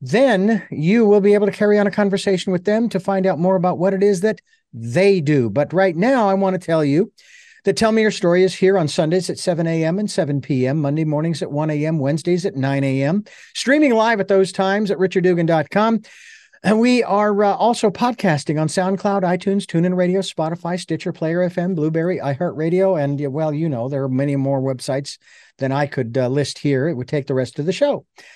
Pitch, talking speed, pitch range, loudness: 185 Hz, 215 wpm, 150-200 Hz, -18 LUFS